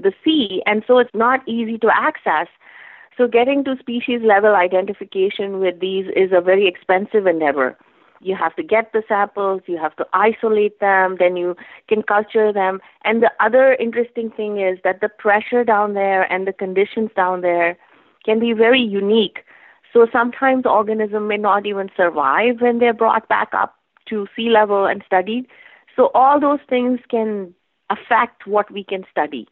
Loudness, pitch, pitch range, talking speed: -17 LUFS, 210 Hz, 190-235 Hz, 175 wpm